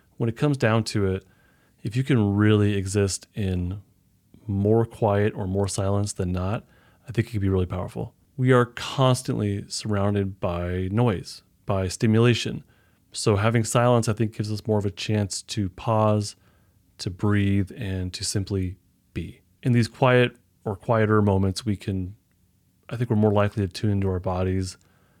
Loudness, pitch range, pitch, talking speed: -24 LUFS, 95-115 Hz, 105 Hz, 170 wpm